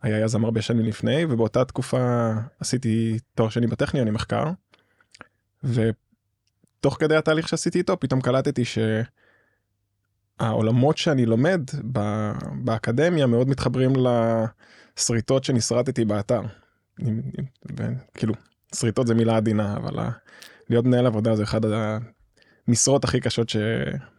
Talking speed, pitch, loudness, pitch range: 105 wpm, 120 Hz, -23 LUFS, 110-130 Hz